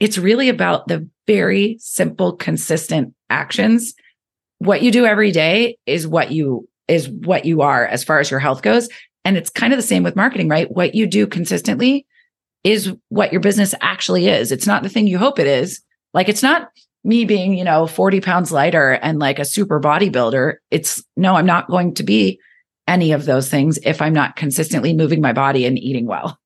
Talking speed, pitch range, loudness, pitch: 200 wpm, 150-215 Hz, -16 LUFS, 185 Hz